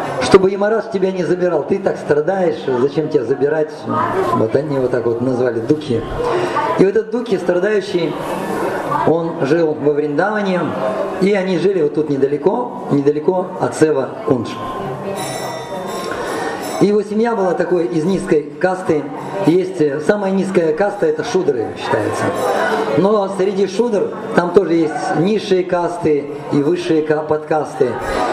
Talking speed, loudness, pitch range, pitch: 140 wpm, -17 LUFS, 155-200 Hz, 175 Hz